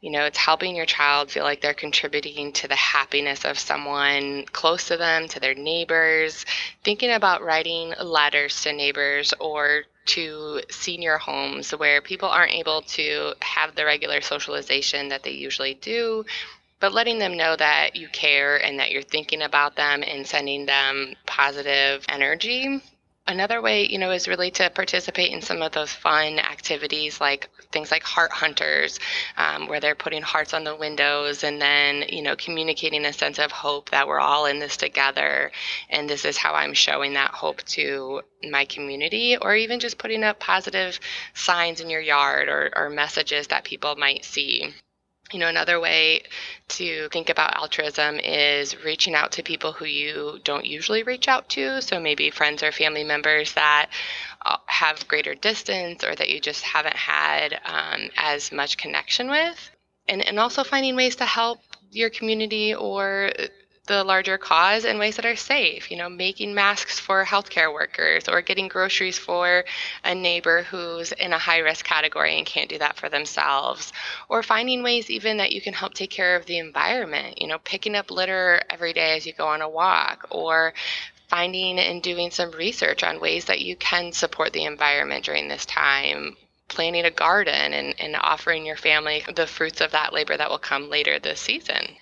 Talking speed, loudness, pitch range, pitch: 180 wpm, -22 LUFS, 145-190 Hz, 160 Hz